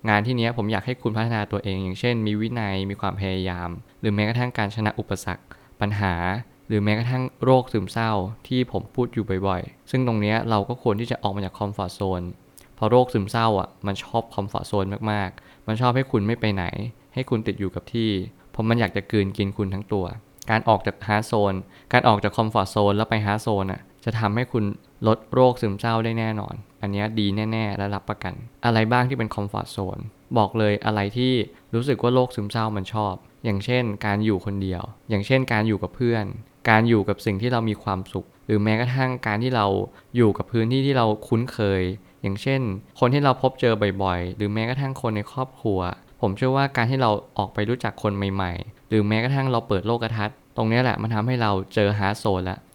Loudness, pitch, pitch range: -24 LUFS, 110 Hz, 100-120 Hz